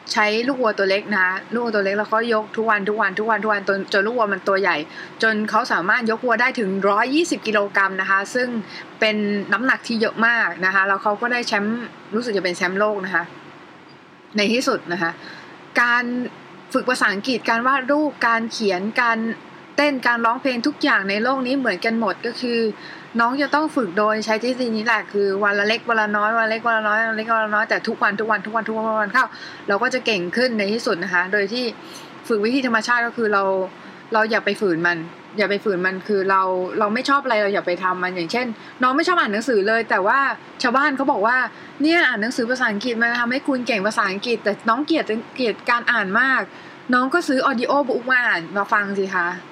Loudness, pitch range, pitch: -20 LUFS, 200-240 Hz, 220 Hz